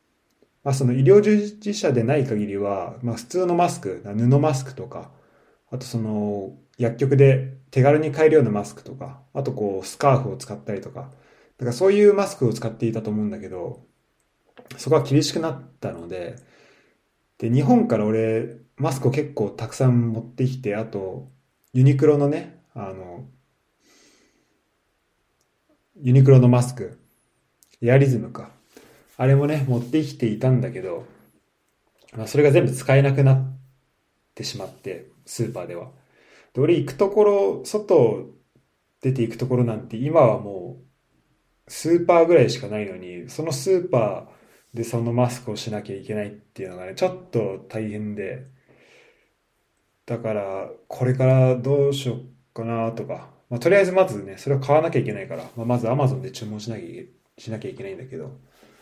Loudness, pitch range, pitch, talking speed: -21 LUFS, 115-140 Hz, 125 Hz, 320 characters per minute